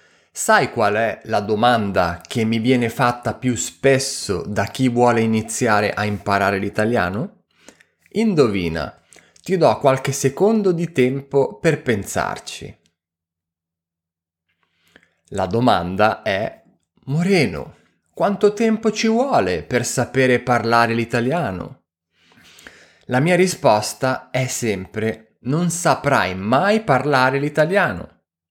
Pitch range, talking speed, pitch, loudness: 105-140 Hz, 105 wpm, 120 Hz, -19 LUFS